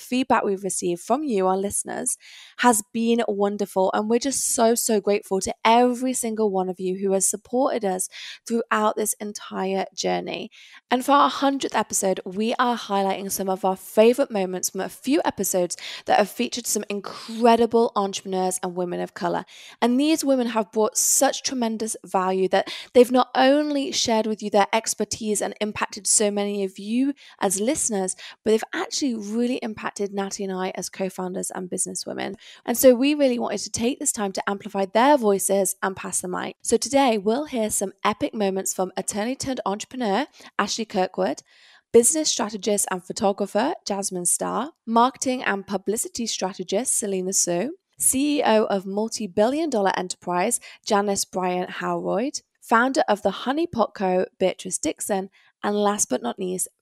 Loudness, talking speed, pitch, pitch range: -23 LUFS, 165 wpm, 210 Hz, 195-240 Hz